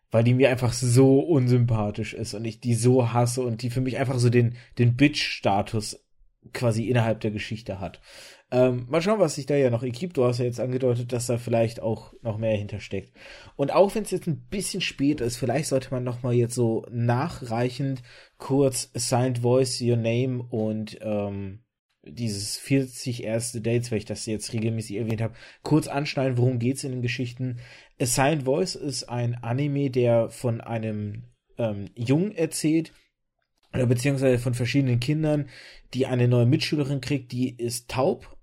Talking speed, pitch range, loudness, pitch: 175 wpm, 115-135 Hz, -25 LUFS, 125 Hz